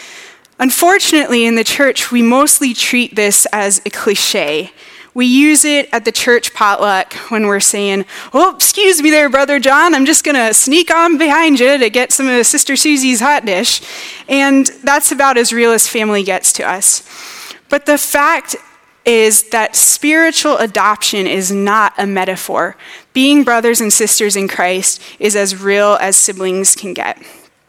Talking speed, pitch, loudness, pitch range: 165 wpm, 245 Hz, -10 LUFS, 210-290 Hz